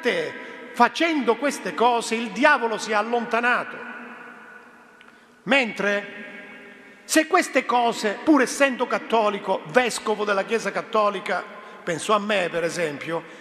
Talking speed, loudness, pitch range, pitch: 105 wpm, -22 LUFS, 205-245 Hz, 230 Hz